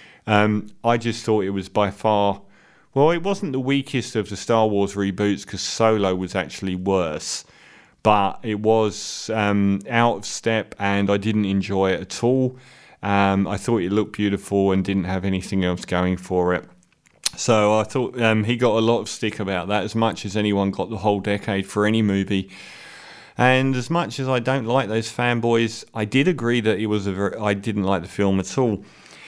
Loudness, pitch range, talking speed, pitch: -21 LUFS, 100-115 Hz, 200 wpm, 105 Hz